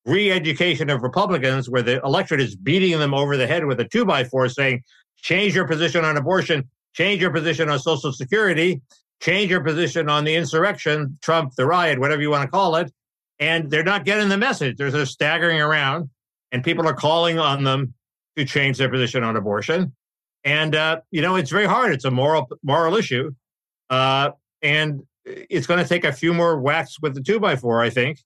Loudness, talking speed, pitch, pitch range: -20 LUFS, 200 wpm, 155 Hz, 135-170 Hz